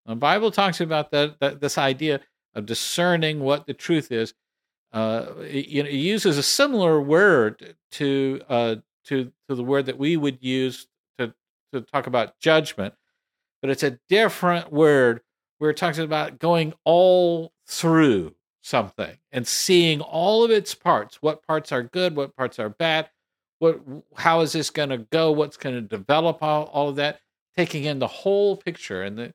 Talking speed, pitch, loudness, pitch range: 175 wpm, 150 Hz, -22 LUFS, 135-165 Hz